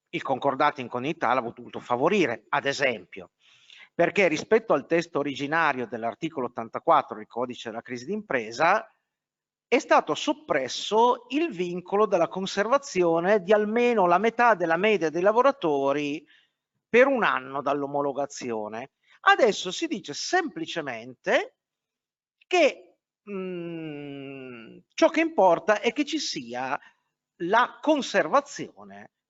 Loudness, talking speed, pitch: -25 LUFS, 115 wpm, 175 Hz